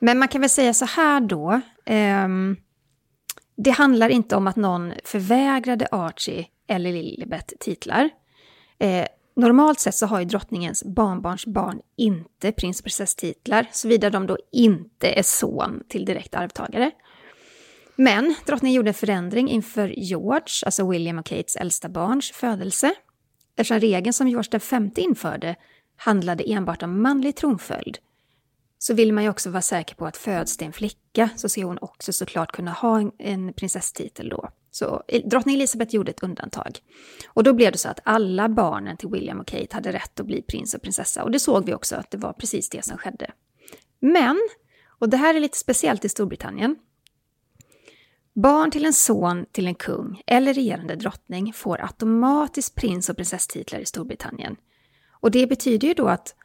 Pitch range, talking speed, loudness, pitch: 185-255 Hz, 170 wpm, -22 LUFS, 220 Hz